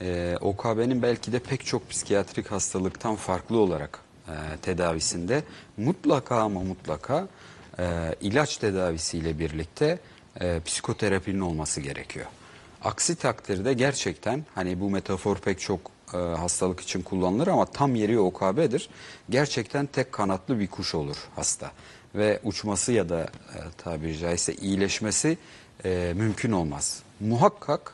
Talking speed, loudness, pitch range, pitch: 125 wpm, -27 LUFS, 90-120 Hz, 100 Hz